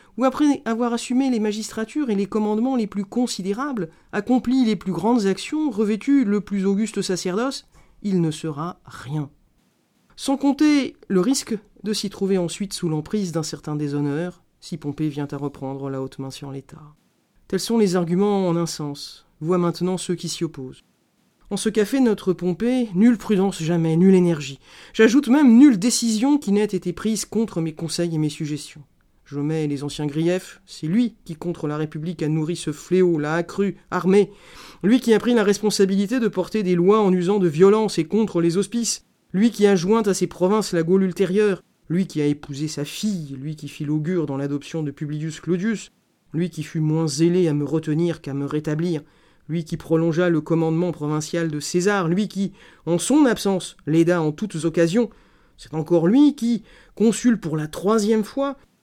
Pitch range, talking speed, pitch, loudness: 160-215 Hz, 190 wpm, 180 Hz, -21 LUFS